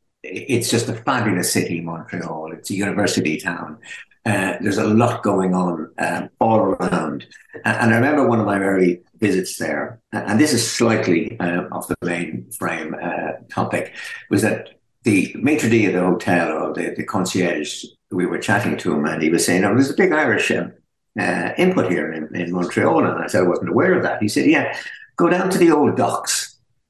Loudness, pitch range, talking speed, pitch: -19 LUFS, 85-115 Hz, 200 wpm, 90 Hz